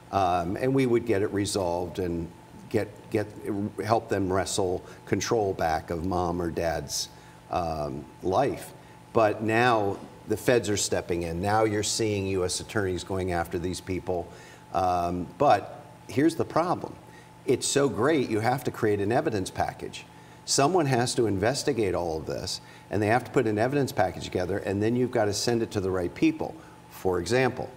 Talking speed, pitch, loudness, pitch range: 175 wpm, 100 Hz, -27 LUFS, 90-110 Hz